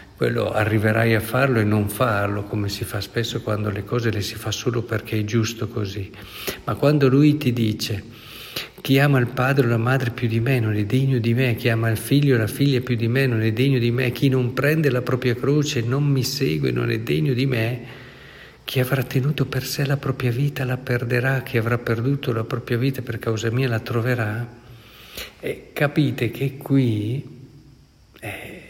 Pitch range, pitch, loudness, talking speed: 115-135 Hz, 120 Hz, -22 LUFS, 205 wpm